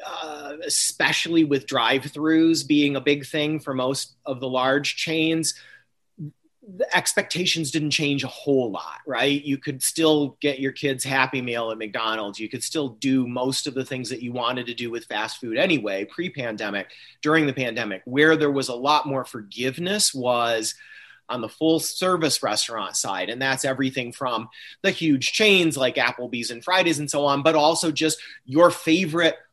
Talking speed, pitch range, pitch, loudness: 180 wpm, 130-160 Hz, 140 Hz, -22 LUFS